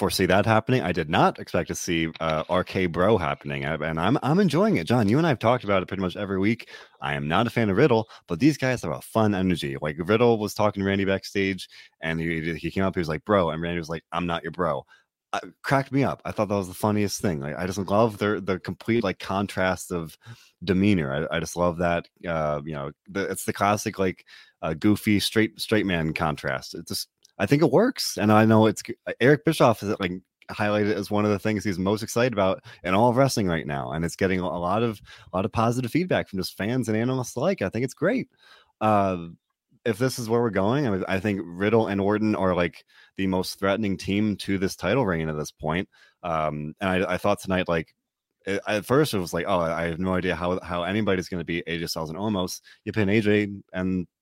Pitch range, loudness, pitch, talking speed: 85-110 Hz, -25 LUFS, 95 Hz, 240 wpm